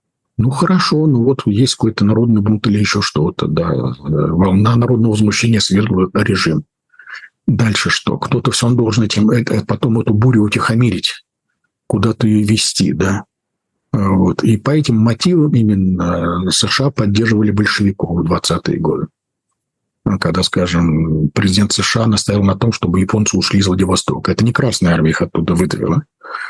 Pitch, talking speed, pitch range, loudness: 110 Hz, 145 wpm, 95-120 Hz, -14 LUFS